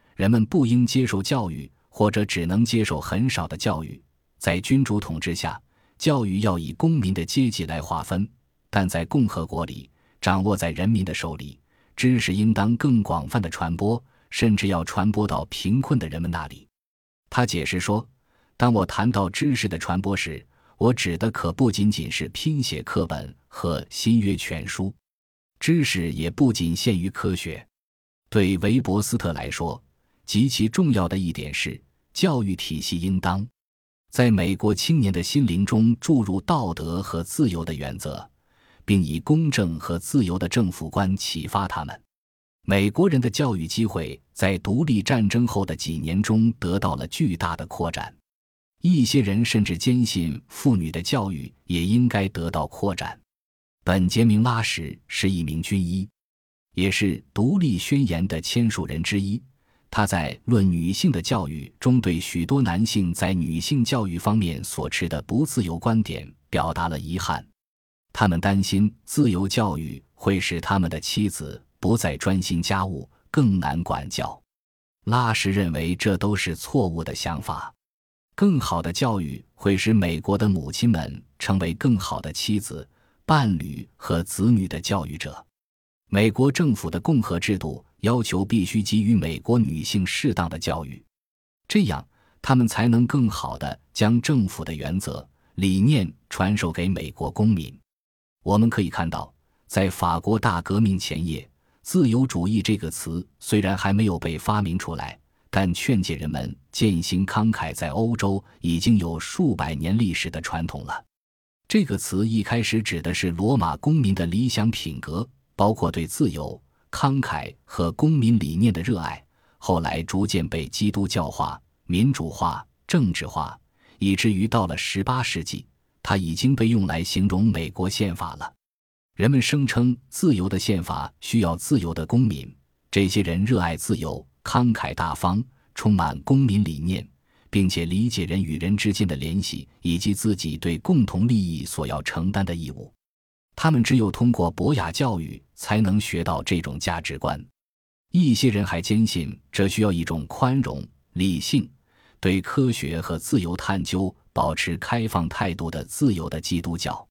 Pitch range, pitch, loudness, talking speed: 85-115 Hz, 100 Hz, -23 LUFS, 240 characters per minute